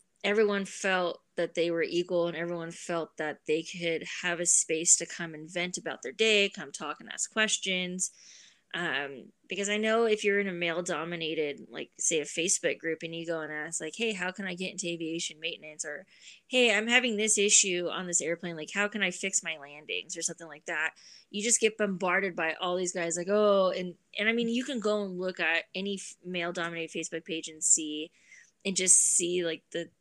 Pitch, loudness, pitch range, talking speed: 175 Hz, -29 LUFS, 165-200 Hz, 210 wpm